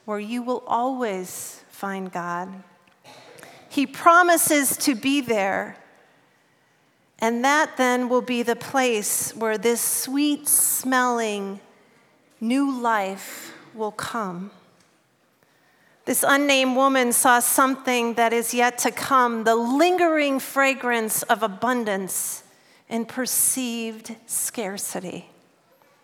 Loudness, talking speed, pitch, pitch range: -21 LUFS, 100 wpm, 240 Hz, 220-265 Hz